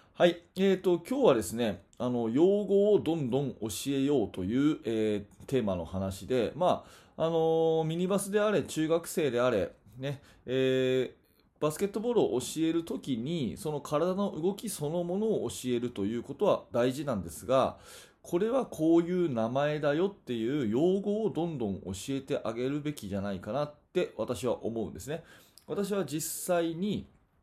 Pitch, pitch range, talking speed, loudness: 150 Hz, 120-185 Hz, 325 characters per minute, -30 LUFS